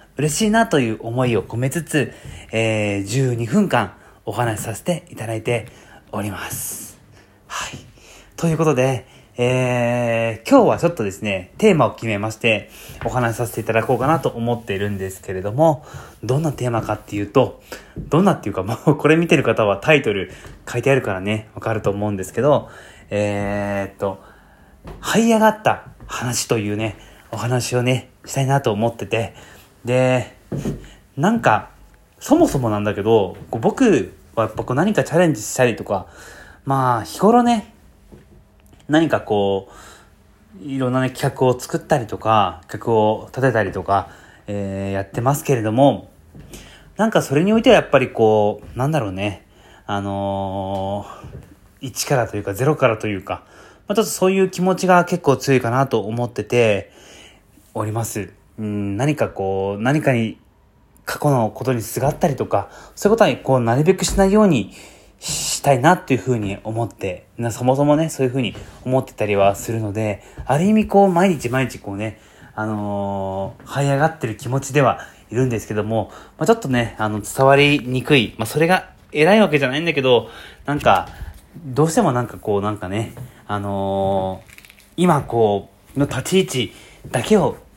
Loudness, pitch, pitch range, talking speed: -19 LUFS, 115 Hz, 105-140 Hz, 325 characters per minute